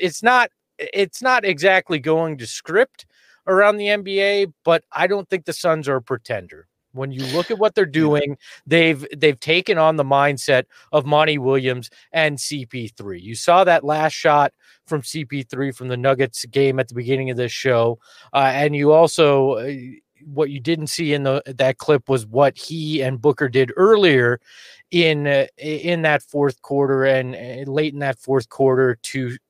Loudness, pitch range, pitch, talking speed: -18 LUFS, 135-165 Hz, 145 Hz, 185 wpm